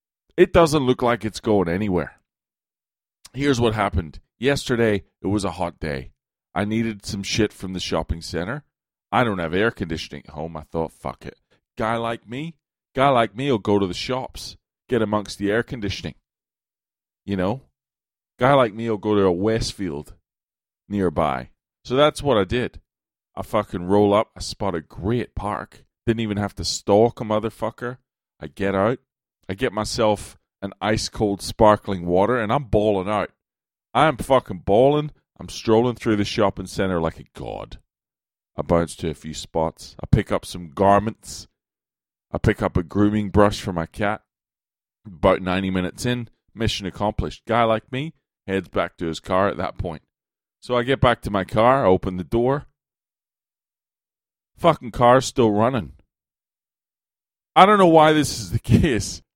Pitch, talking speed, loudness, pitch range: 105 Hz, 175 wpm, -21 LUFS, 90-115 Hz